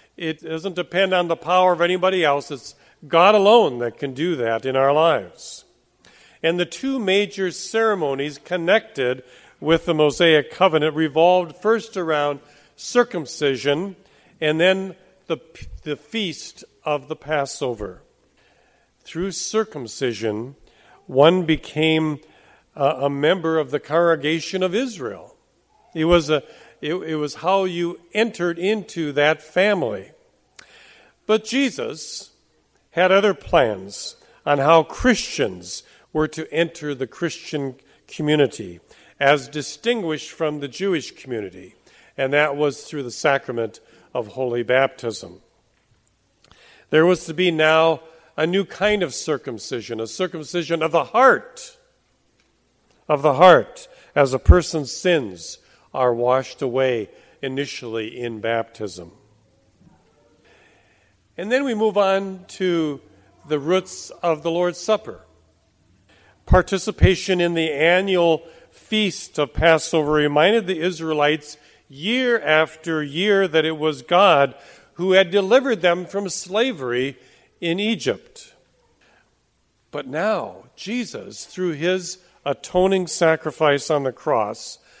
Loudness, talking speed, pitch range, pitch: -20 LUFS, 120 wpm, 140-185 Hz, 160 Hz